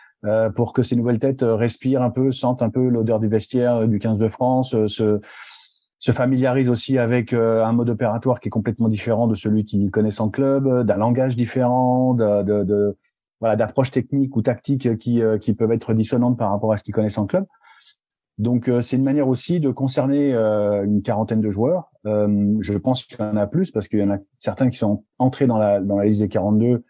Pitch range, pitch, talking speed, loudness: 105-125 Hz, 115 Hz, 230 wpm, -20 LUFS